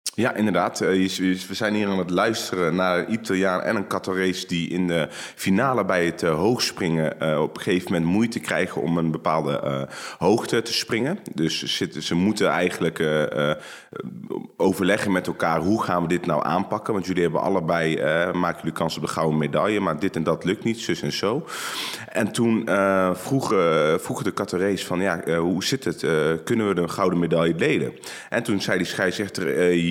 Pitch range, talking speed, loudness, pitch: 85-95 Hz, 185 wpm, -23 LUFS, 90 Hz